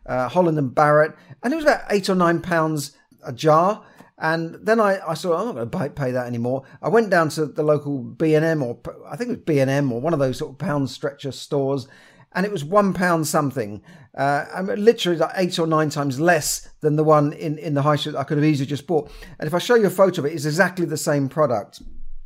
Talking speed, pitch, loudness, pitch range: 250 wpm, 155 Hz, -21 LUFS, 140-175 Hz